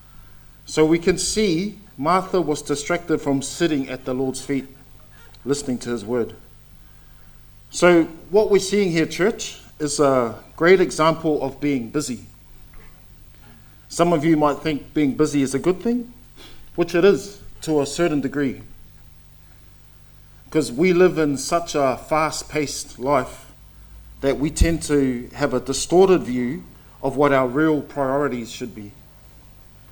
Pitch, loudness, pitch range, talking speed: 140 Hz, -21 LUFS, 125-160 Hz, 145 wpm